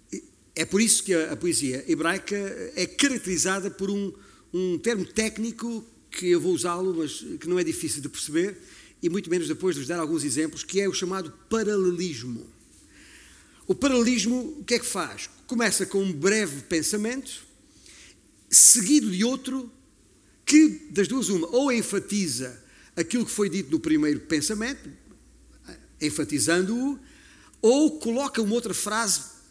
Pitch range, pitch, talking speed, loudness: 170-240 Hz, 195 Hz, 150 wpm, -23 LUFS